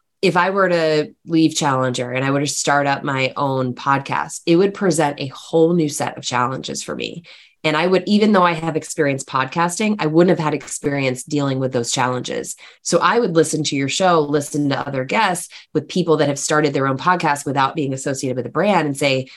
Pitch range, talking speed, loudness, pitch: 135-170 Hz, 220 wpm, -18 LUFS, 150 Hz